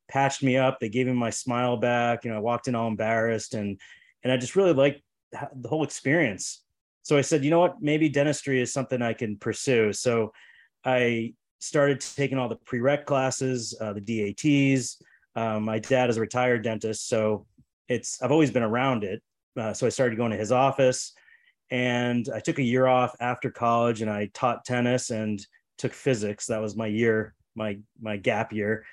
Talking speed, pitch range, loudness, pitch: 195 wpm, 110-130 Hz, -26 LUFS, 120 Hz